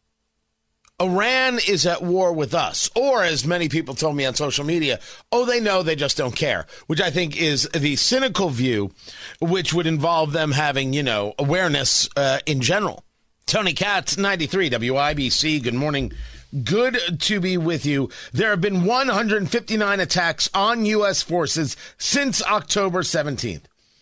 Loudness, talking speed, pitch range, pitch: -21 LUFS, 155 wpm, 145-195 Hz, 165 Hz